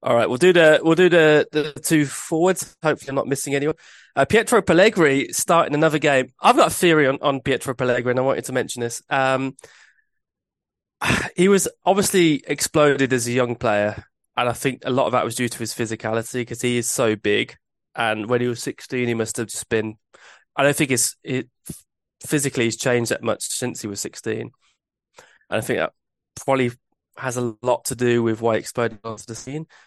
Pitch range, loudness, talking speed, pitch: 120-145 Hz, -20 LUFS, 205 wpm, 130 Hz